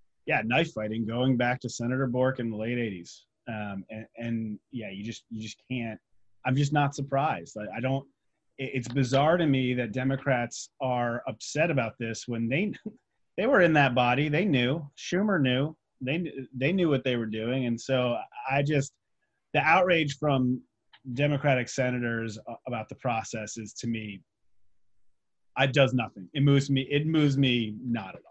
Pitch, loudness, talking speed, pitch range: 125 Hz, -28 LUFS, 180 wpm, 110-140 Hz